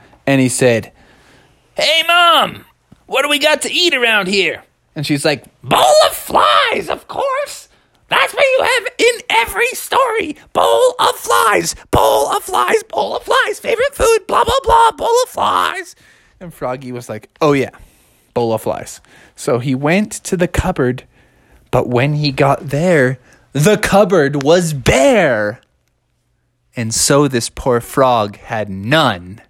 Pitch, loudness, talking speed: 155 Hz, -14 LUFS, 155 wpm